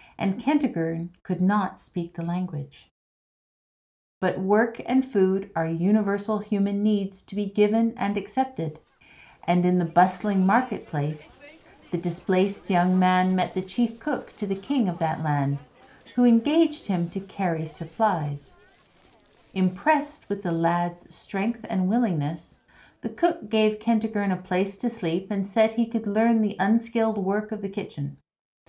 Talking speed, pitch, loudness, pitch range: 150 wpm, 195 Hz, -25 LUFS, 175-220 Hz